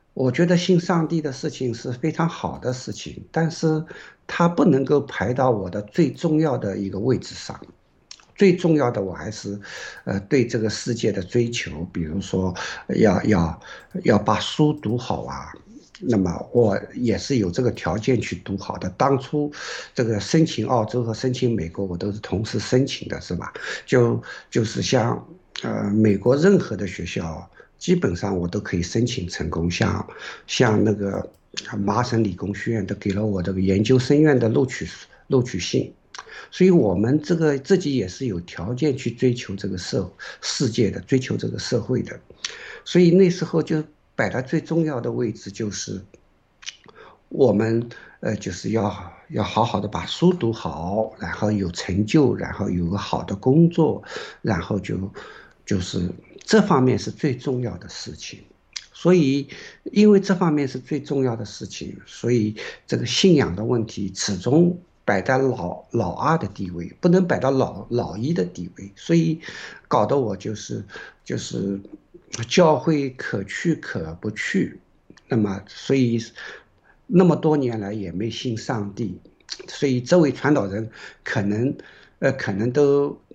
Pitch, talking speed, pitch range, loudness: 115 Hz, 230 characters per minute, 100-145 Hz, -22 LUFS